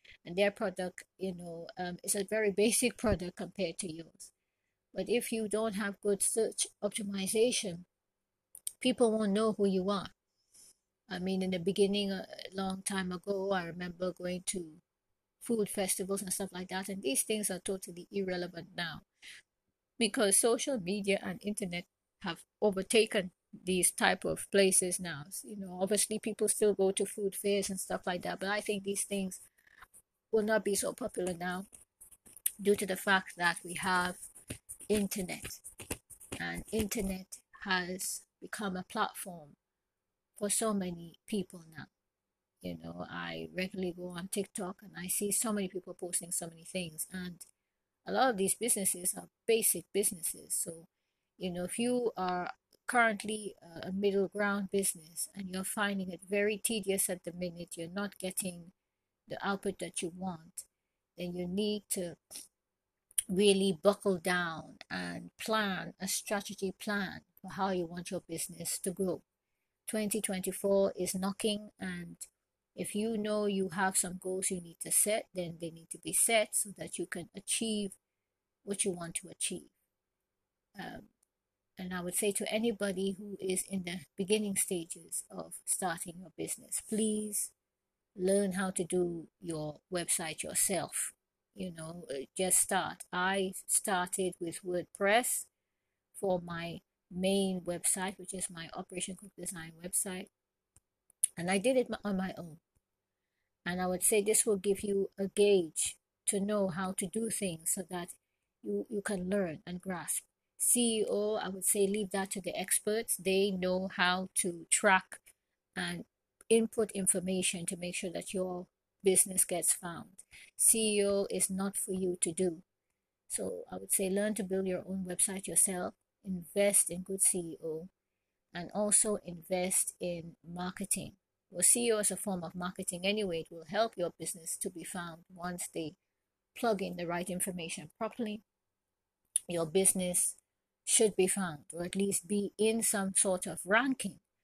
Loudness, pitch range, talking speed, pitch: -33 LUFS, 180-205 Hz, 155 wpm, 190 Hz